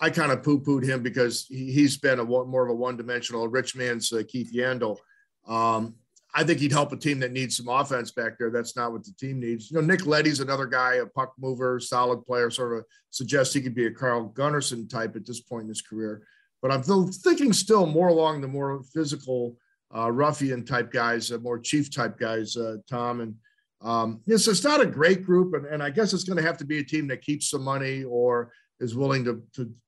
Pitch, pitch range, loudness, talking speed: 130 Hz, 120-150 Hz, -26 LUFS, 230 wpm